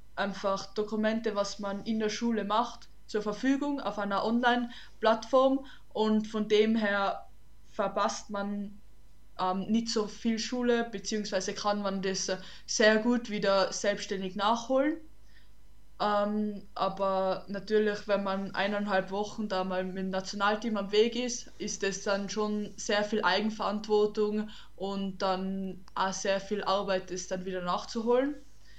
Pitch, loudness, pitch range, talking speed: 205 Hz, -30 LUFS, 195-220 Hz, 135 wpm